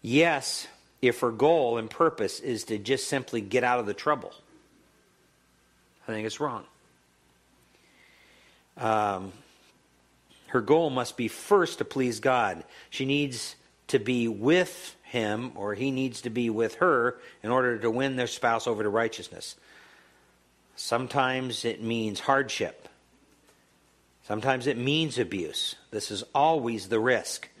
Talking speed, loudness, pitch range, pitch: 135 wpm, -28 LUFS, 100-130 Hz, 115 Hz